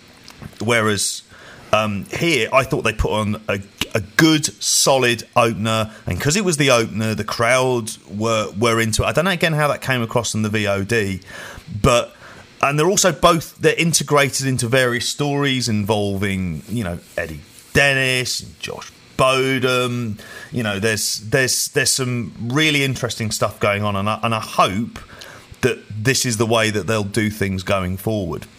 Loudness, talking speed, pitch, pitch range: -18 LUFS, 170 wpm, 115 Hz, 105-130 Hz